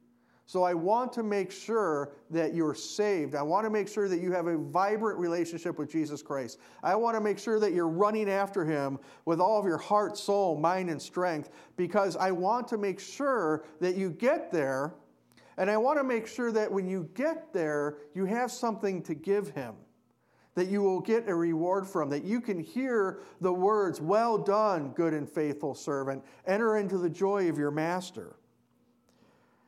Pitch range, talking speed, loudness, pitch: 160-210 Hz, 190 wpm, -30 LUFS, 185 Hz